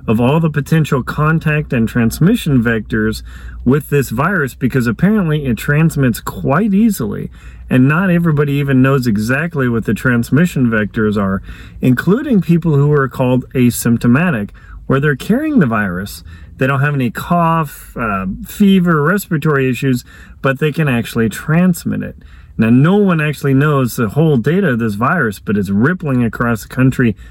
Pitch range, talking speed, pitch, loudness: 115-160 Hz, 155 wpm, 135 Hz, -14 LUFS